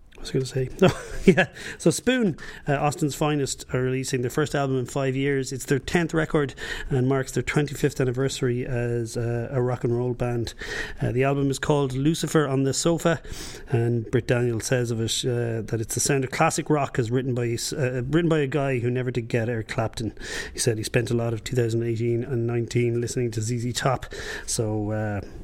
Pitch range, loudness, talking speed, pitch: 120-140 Hz, -25 LUFS, 210 wpm, 125 Hz